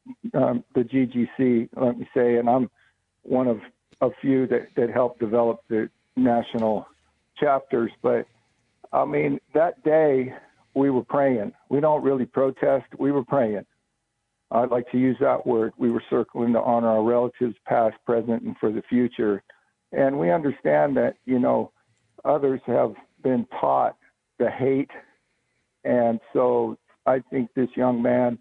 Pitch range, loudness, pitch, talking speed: 115-130 Hz, -23 LUFS, 125 Hz, 150 wpm